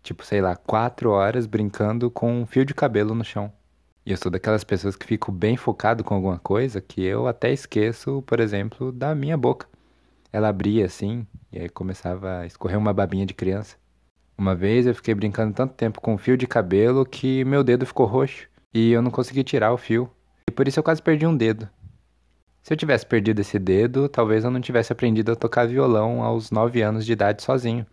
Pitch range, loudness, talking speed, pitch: 100-125 Hz, -22 LUFS, 210 wpm, 110 Hz